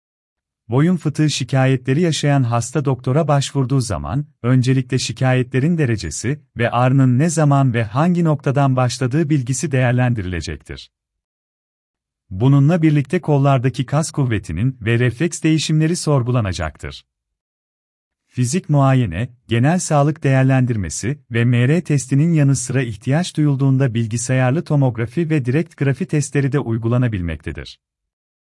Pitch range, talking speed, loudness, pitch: 115-145 Hz, 105 wpm, -17 LUFS, 130 Hz